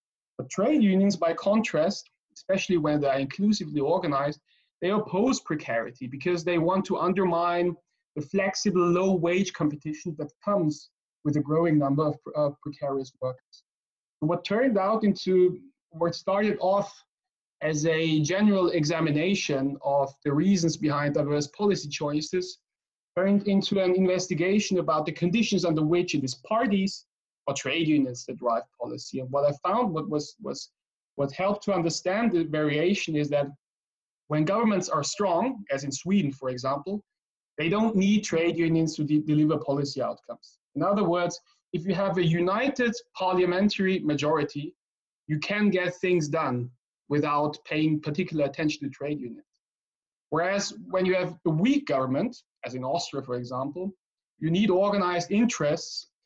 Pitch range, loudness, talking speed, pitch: 150-195 Hz, -26 LUFS, 150 wpm, 170 Hz